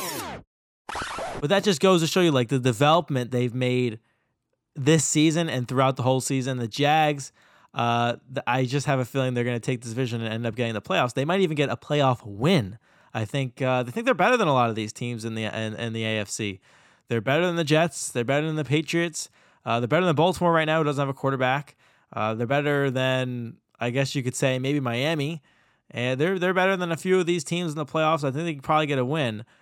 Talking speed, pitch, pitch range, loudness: 245 wpm, 135 Hz, 120-155 Hz, -24 LUFS